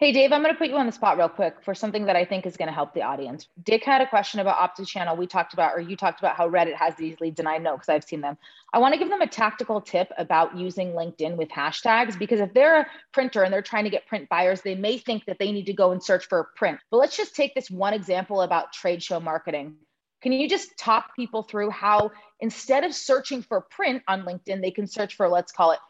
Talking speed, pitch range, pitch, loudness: 270 wpm, 175-235 Hz, 200 Hz, -24 LUFS